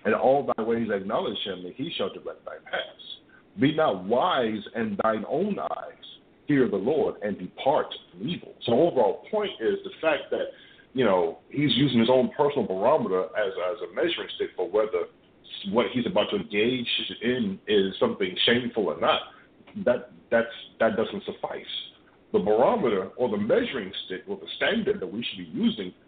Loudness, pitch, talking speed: -26 LUFS, 230 Hz, 180 wpm